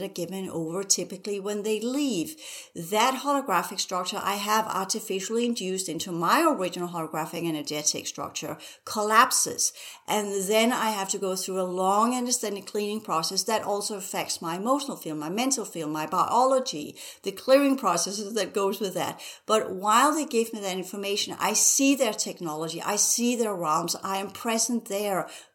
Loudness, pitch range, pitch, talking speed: -26 LUFS, 185-225 Hz, 200 Hz, 165 wpm